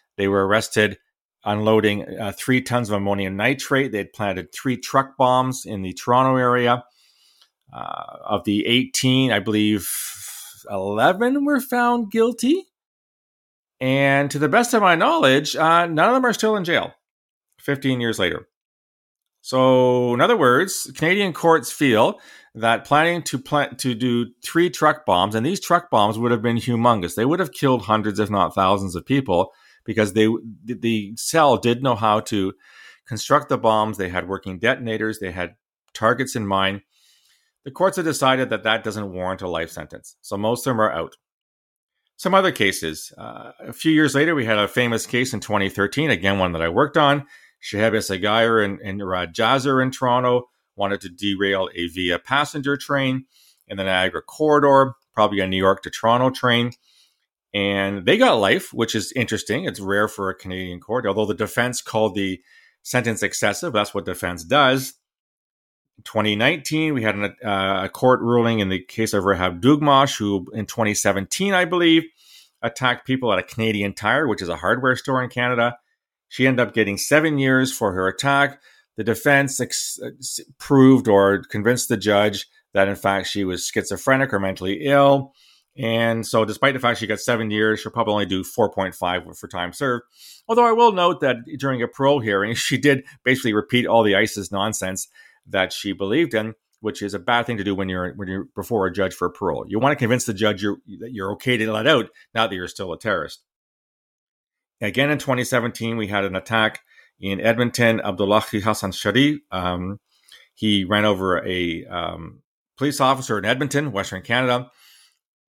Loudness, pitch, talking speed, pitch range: -20 LUFS, 115 Hz, 180 wpm, 100-130 Hz